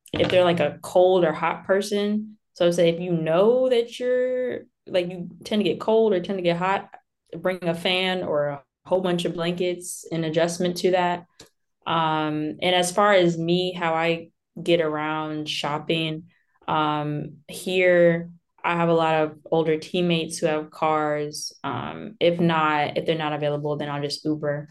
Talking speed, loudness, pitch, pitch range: 180 wpm, -23 LUFS, 170 Hz, 155-185 Hz